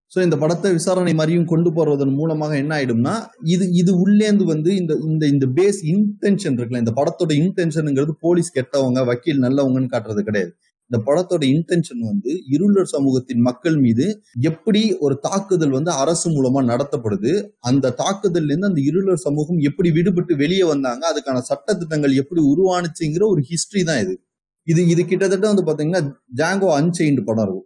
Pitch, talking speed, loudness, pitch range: 160 Hz, 155 wpm, -18 LUFS, 140-185 Hz